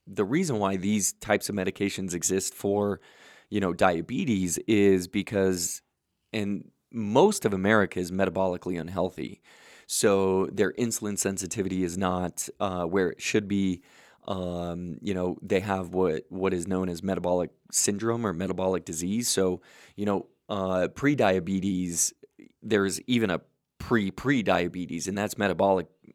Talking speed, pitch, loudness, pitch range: 140 wpm, 95 Hz, -27 LUFS, 90-105 Hz